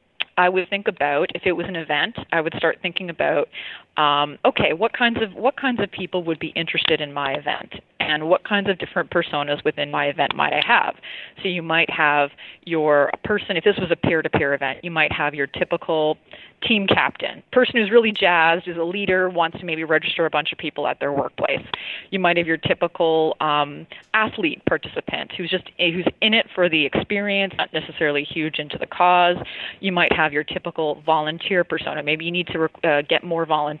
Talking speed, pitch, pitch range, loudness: 210 wpm, 165 Hz, 150-185 Hz, -21 LUFS